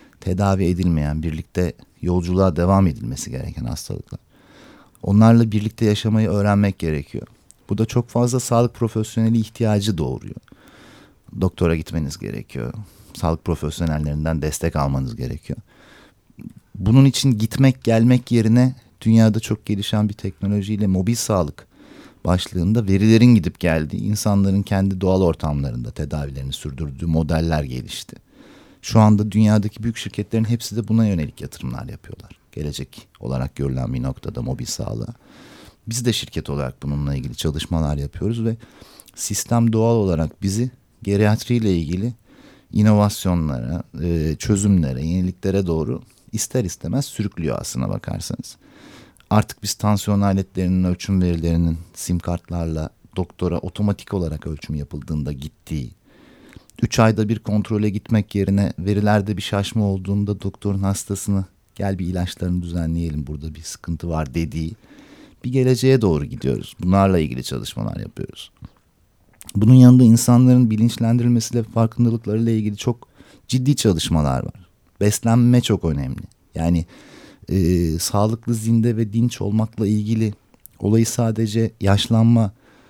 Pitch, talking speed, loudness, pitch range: 100 Hz, 115 wpm, -20 LUFS, 85-110 Hz